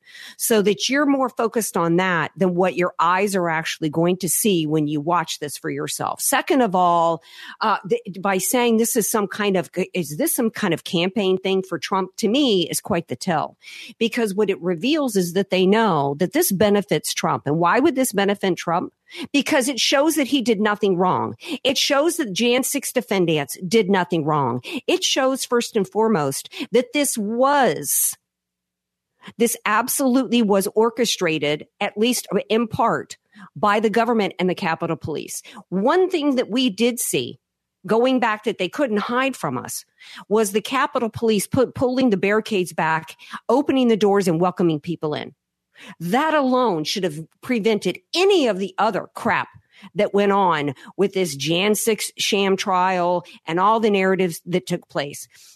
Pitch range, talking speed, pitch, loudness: 180-240 Hz, 175 wpm, 205 Hz, -20 LUFS